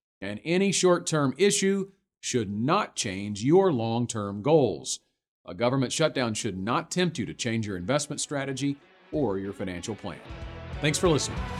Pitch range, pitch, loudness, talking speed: 105-160 Hz, 125 Hz, -27 LUFS, 160 wpm